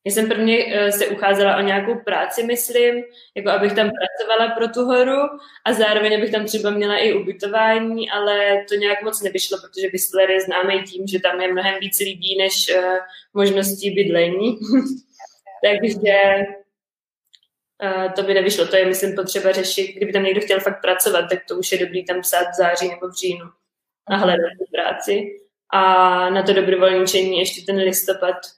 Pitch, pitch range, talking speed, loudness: 195 Hz, 185-210 Hz, 175 wpm, -18 LUFS